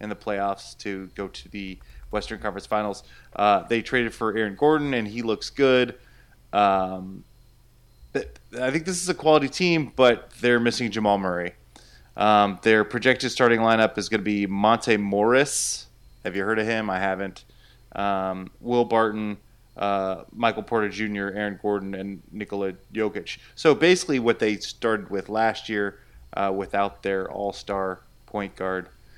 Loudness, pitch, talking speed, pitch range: -24 LUFS, 105 Hz, 160 wpm, 100-115 Hz